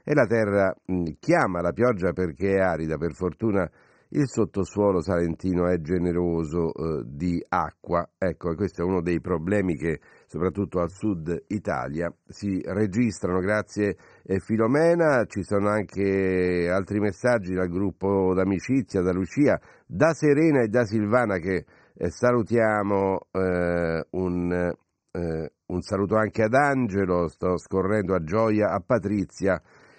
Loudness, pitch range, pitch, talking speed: -25 LUFS, 90-105 Hz, 95 Hz, 135 wpm